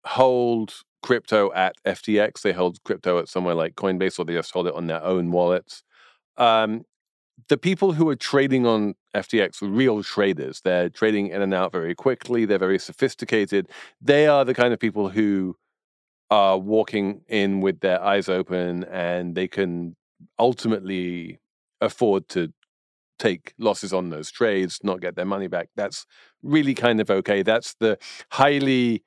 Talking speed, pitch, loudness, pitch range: 165 wpm, 100 Hz, -22 LUFS, 90-120 Hz